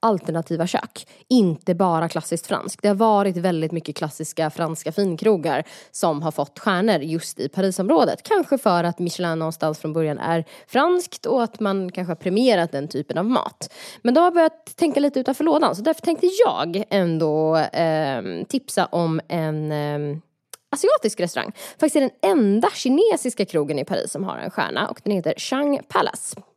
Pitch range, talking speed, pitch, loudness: 160-245 Hz, 175 wpm, 185 Hz, -21 LUFS